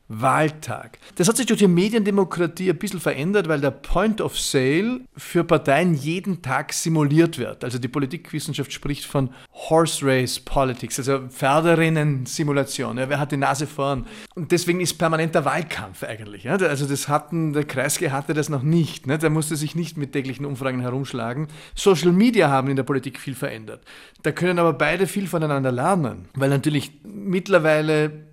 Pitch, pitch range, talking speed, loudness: 150 Hz, 135-170 Hz, 170 wpm, -22 LUFS